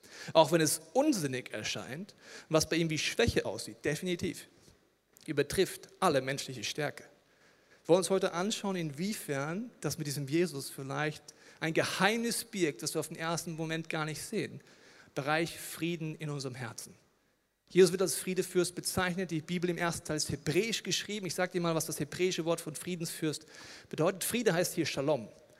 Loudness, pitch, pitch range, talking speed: -33 LUFS, 165 Hz, 155-185 Hz, 170 wpm